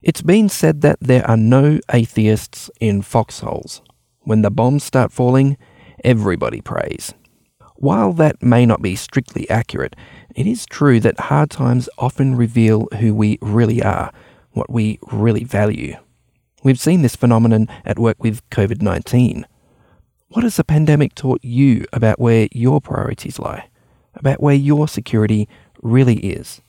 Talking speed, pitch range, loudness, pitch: 145 wpm, 110-135 Hz, -16 LUFS, 120 Hz